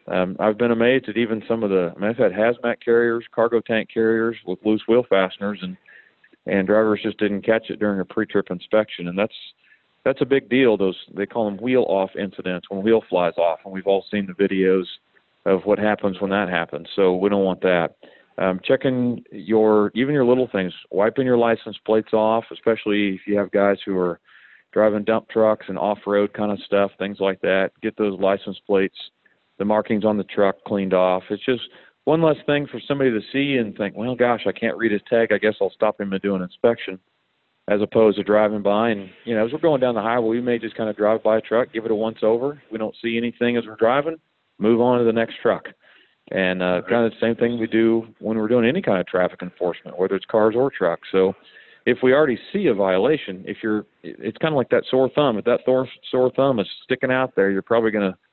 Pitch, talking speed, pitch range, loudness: 110 Hz, 235 wpm, 100-115 Hz, -21 LUFS